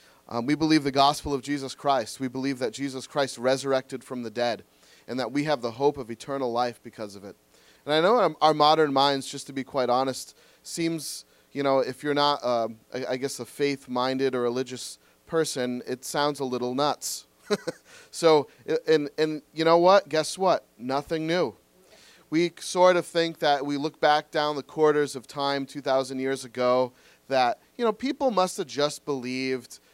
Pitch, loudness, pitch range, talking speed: 140 Hz, -26 LUFS, 125-155 Hz, 190 wpm